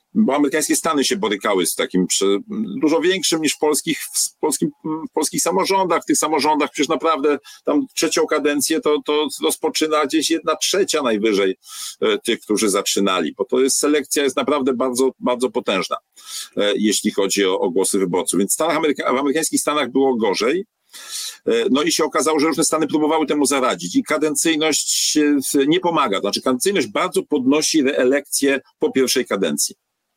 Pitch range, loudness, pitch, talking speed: 140-190 Hz, -18 LUFS, 155 Hz, 165 wpm